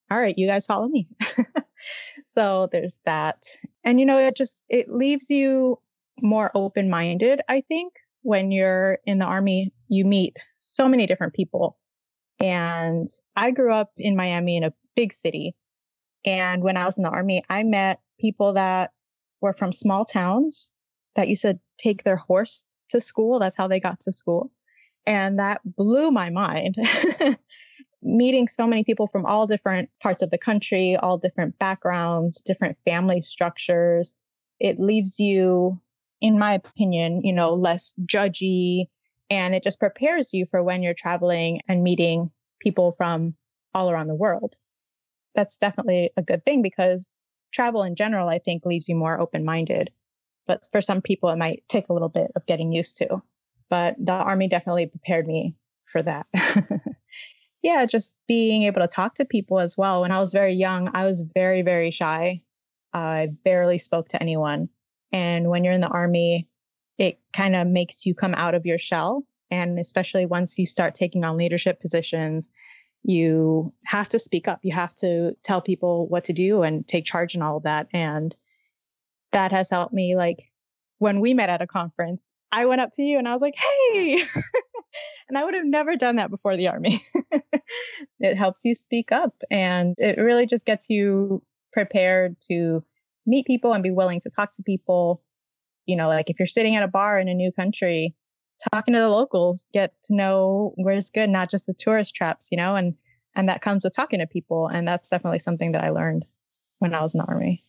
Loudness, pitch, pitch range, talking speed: -23 LUFS, 190 Hz, 175-215 Hz, 185 wpm